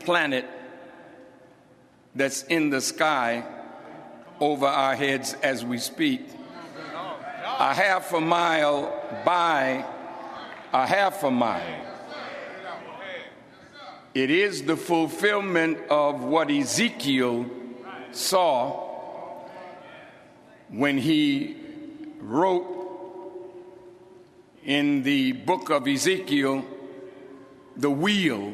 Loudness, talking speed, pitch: -24 LUFS, 80 wpm, 185 Hz